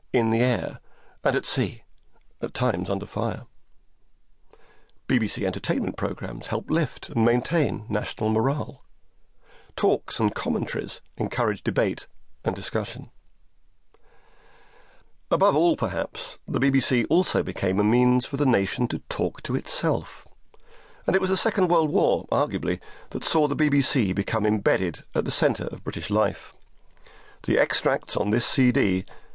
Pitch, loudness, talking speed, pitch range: 125 Hz, -25 LUFS, 135 wpm, 110-155 Hz